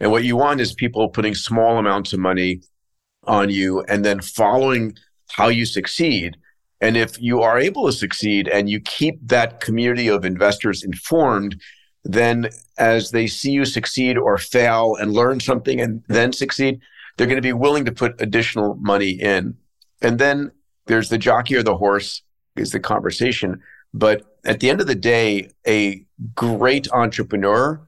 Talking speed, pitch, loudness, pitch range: 170 wpm, 115 Hz, -18 LUFS, 100-120 Hz